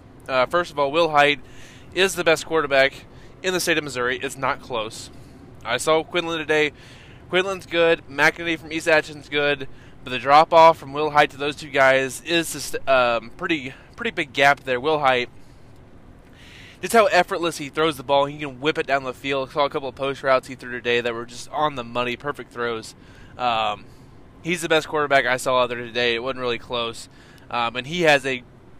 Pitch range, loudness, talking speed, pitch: 125-155 Hz, -21 LUFS, 210 wpm, 135 Hz